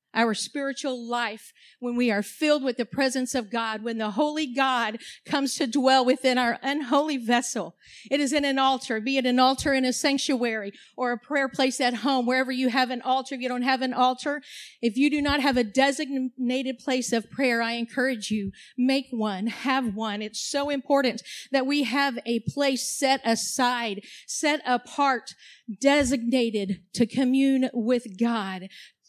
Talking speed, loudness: 175 wpm, -25 LUFS